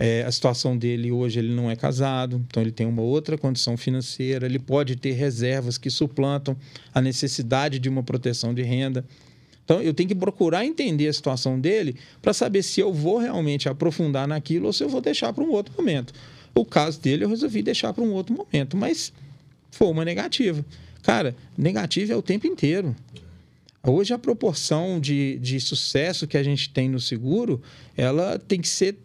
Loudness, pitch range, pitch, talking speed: -24 LUFS, 130-165 Hz, 140 Hz, 190 wpm